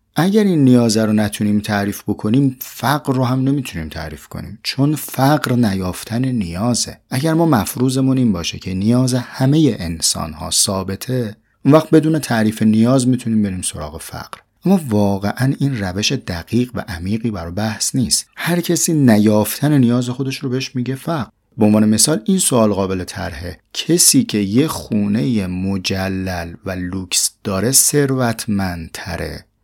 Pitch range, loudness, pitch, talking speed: 100-135 Hz, -16 LUFS, 115 Hz, 145 wpm